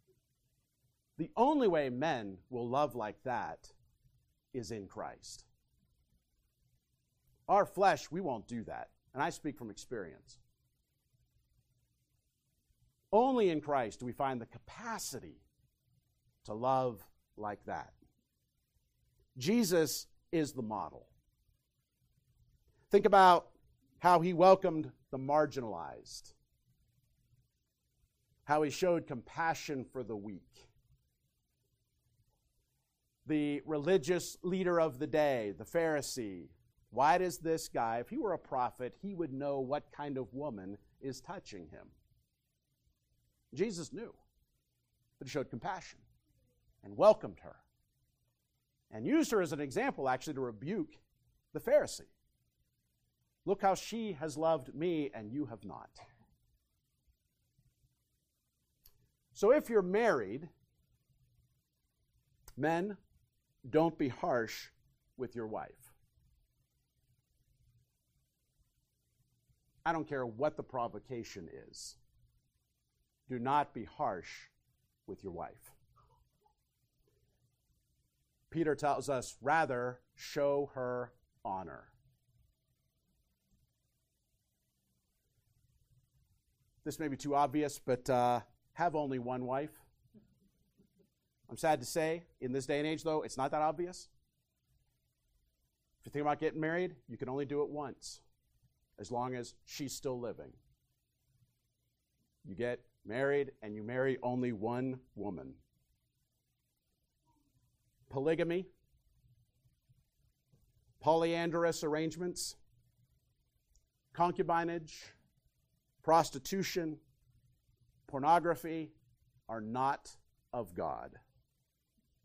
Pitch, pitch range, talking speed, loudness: 130 Hz, 120-160 Hz, 100 wpm, -35 LUFS